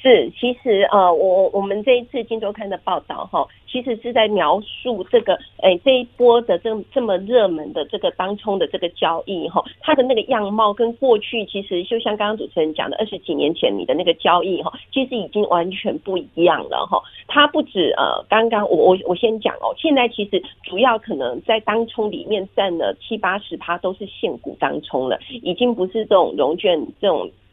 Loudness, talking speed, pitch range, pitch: -19 LUFS, 300 characters per minute, 190-245 Hz, 215 Hz